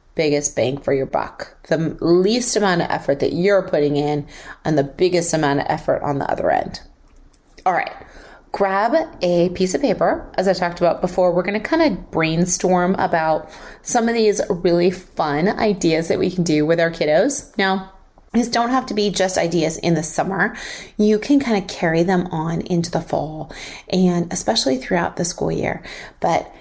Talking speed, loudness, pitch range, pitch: 190 wpm, -19 LUFS, 160-195 Hz, 180 Hz